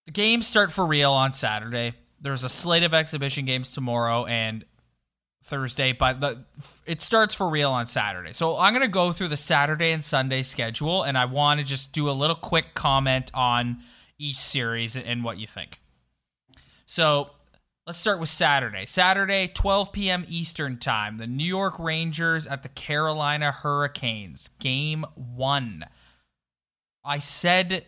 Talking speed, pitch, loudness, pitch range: 160 wpm, 140 Hz, -24 LUFS, 125-165 Hz